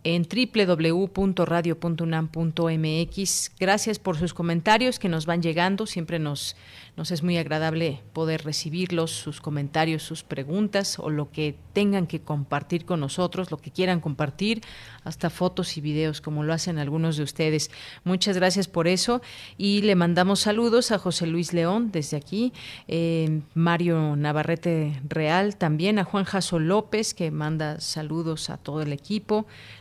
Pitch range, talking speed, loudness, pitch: 155-185 Hz, 150 wpm, -25 LUFS, 170 Hz